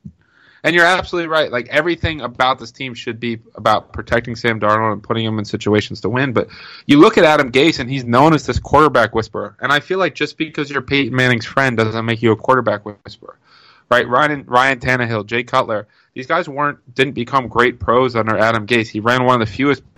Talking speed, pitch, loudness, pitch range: 220 wpm, 125 Hz, -16 LUFS, 115-140 Hz